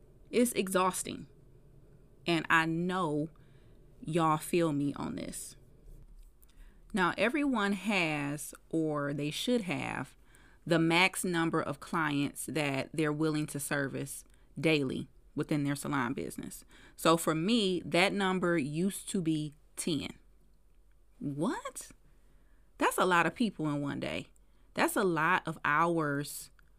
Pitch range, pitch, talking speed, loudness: 145-180 Hz, 160 Hz, 125 wpm, -32 LUFS